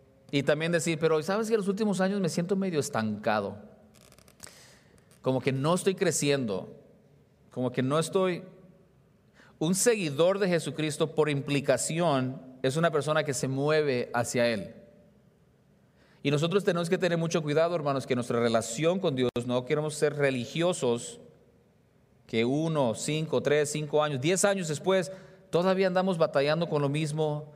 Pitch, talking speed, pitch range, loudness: 155 Hz, 150 wpm, 140-175 Hz, -28 LUFS